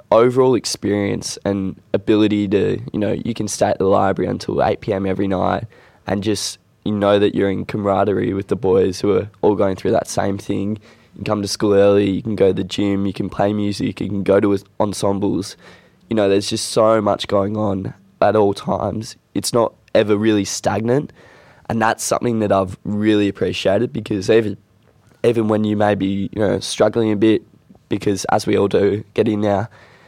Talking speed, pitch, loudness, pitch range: 200 wpm, 105 Hz, -18 LUFS, 100-110 Hz